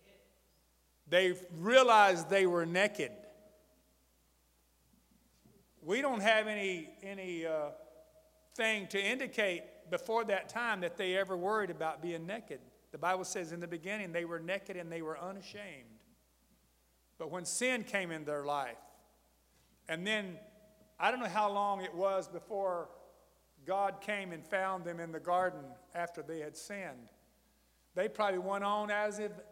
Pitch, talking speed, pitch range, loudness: 185 Hz, 145 wpm, 160-210 Hz, -35 LUFS